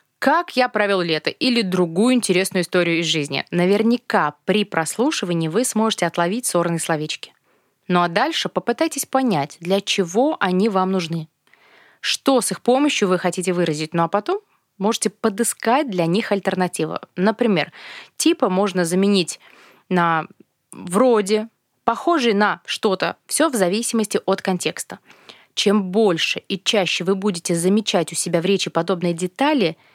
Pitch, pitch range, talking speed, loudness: 195 Hz, 175-225 Hz, 140 wpm, -20 LUFS